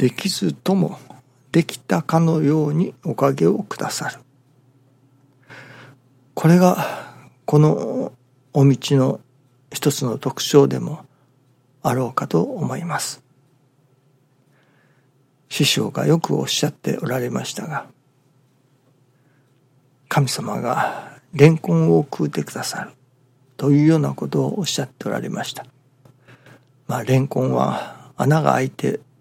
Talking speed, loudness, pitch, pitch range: 225 characters per minute, -20 LUFS, 135 Hz, 130-145 Hz